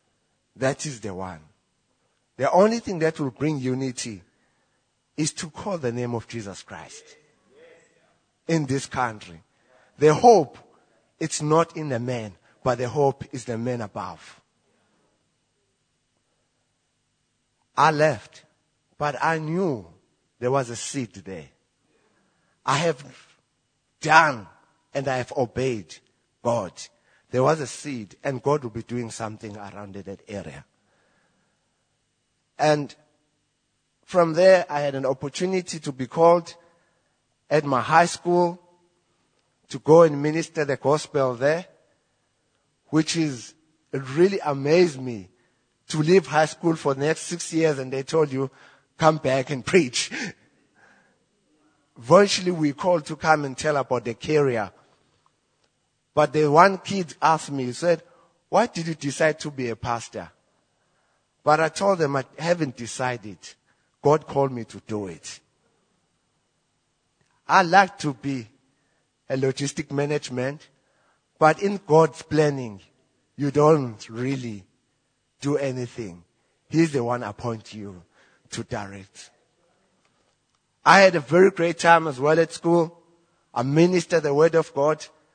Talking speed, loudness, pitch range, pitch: 135 wpm, -23 LUFS, 125-165 Hz, 145 Hz